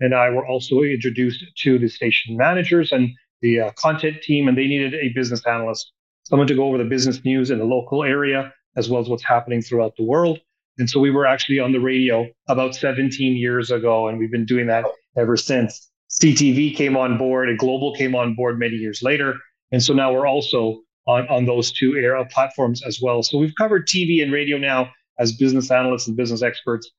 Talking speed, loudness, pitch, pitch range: 215 wpm, -19 LUFS, 130 Hz, 120-135 Hz